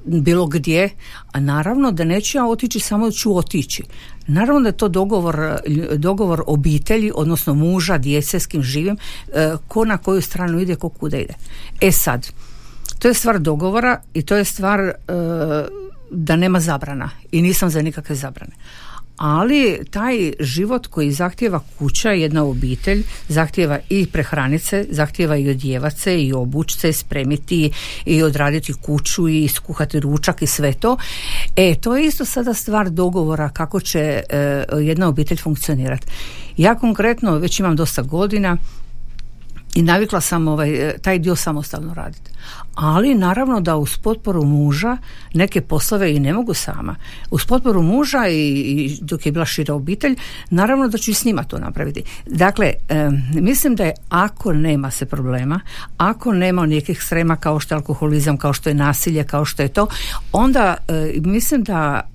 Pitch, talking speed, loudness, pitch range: 165 Hz, 160 wpm, -18 LUFS, 150-195 Hz